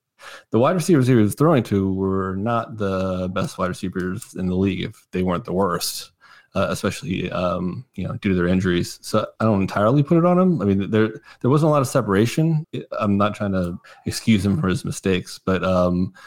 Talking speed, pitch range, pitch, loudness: 215 wpm, 95-120 Hz, 100 Hz, -21 LUFS